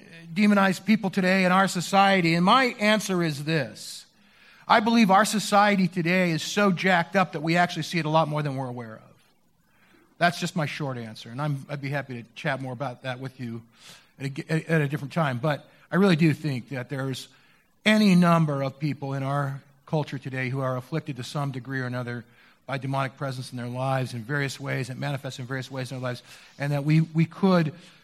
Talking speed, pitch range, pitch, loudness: 215 wpm, 135-175 Hz, 145 Hz, -25 LUFS